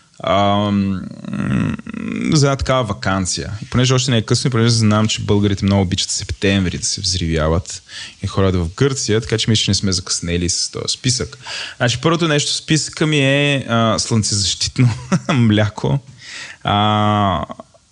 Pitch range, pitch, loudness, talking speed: 100-130 Hz, 110 Hz, -17 LUFS, 150 wpm